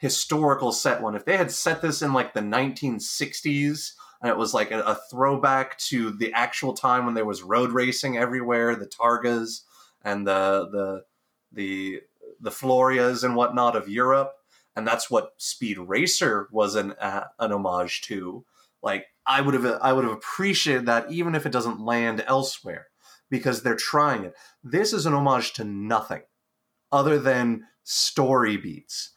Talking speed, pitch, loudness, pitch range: 165 wpm, 125 Hz, -24 LUFS, 115-135 Hz